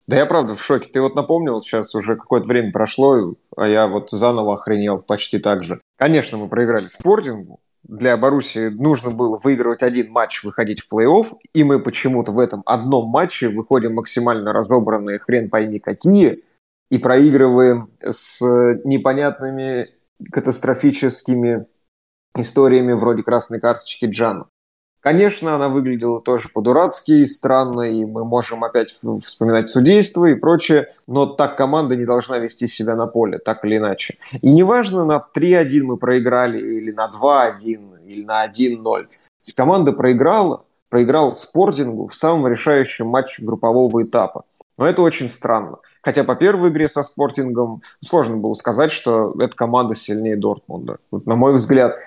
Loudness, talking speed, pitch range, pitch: -16 LUFS, 150 wpm, 110-135 Hz, 120 Hz